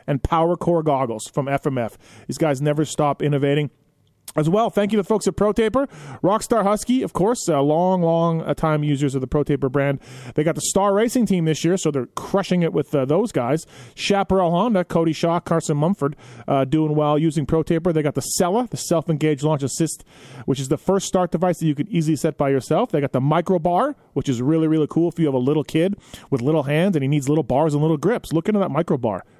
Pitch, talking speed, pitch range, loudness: 155 Hz, 225 wpm, 145-180 Hz, -20 LUFS